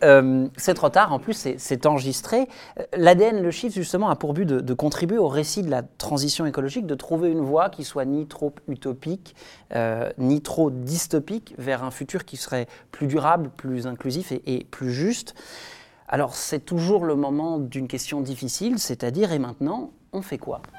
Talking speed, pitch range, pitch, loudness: 185 wpm, 130-170 Hz, 145 Hz, -24 LUFS